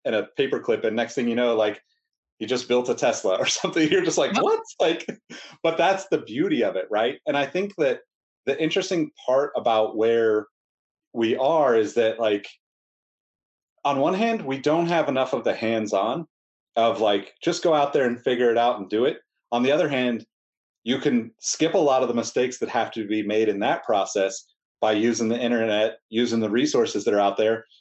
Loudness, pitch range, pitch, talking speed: -23 LUFS, 110-175 Hz, 120 Hz, 210 wpm